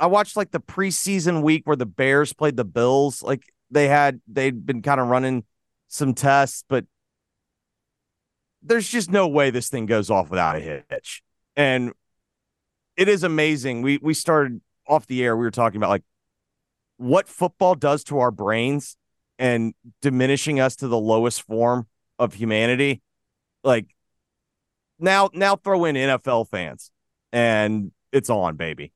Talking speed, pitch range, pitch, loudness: 155 wpm, 115-155 Hz, 135 Hz, -21 LUFS